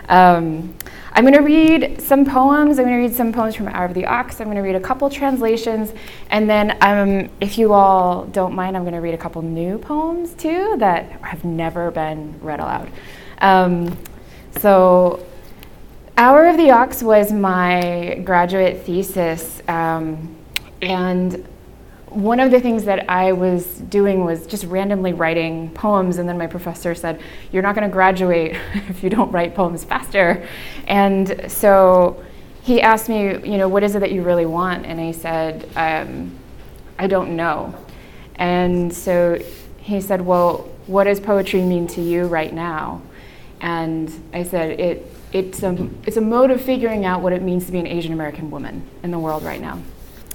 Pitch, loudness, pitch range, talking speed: 185 Hz, -17 LUFS, 170-210 Hz, 180 wpm